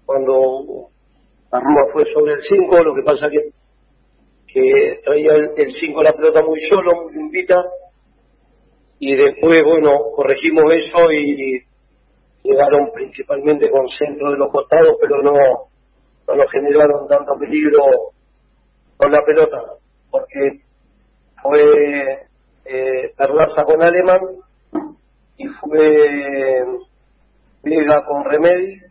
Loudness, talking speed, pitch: -14 LUFS, 115 wpm, 160 Hz